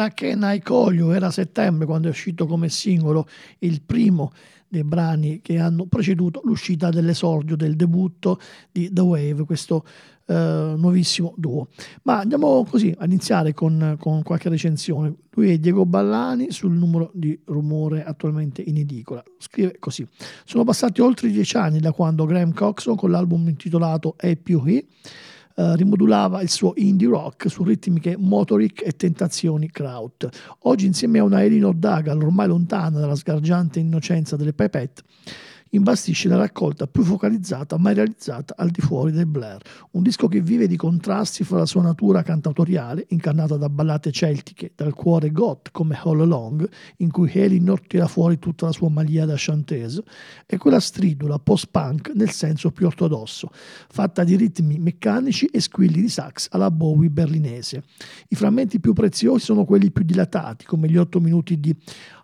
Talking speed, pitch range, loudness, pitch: 160 wpm, 155-195 Hz, -20 LUFS, 170 Hz